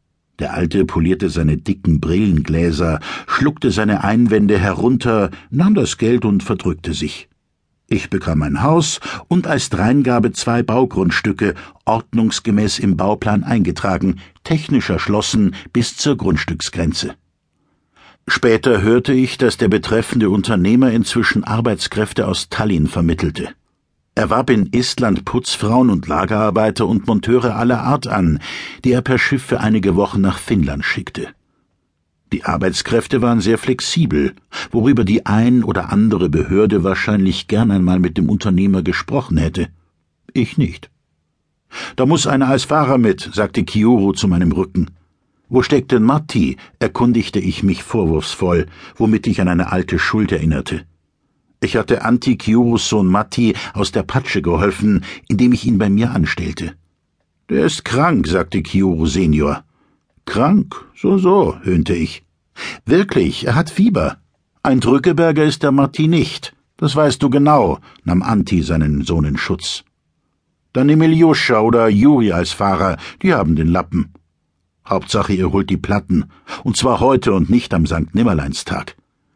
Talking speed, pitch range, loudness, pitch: 140 wpm, 90-125 Hz, -16 LUFS, 105 Hz